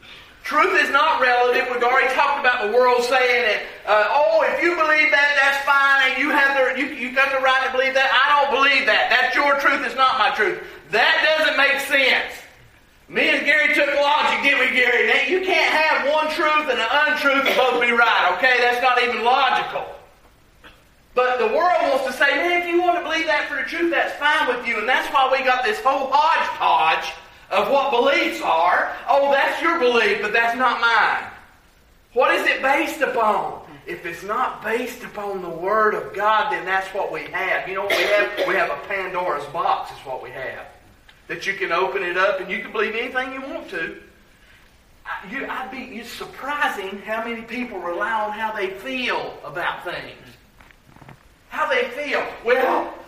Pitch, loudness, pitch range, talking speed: 260 Hz, -19 LUFS, 225-290 Hz, 205 wpm